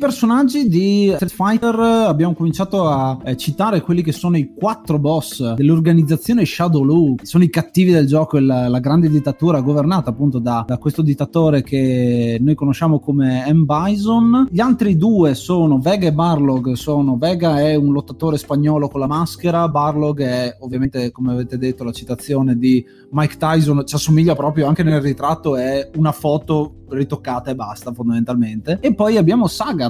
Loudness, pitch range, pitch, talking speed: -16 LUFS, 135-170 Hz, 150 Hz, 170 wpm